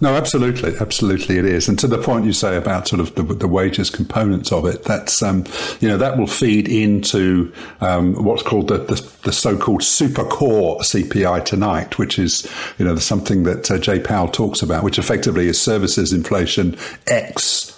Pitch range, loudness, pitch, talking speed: 90-110 Hz, -17 LUFS, 100 Hz, 190 wpm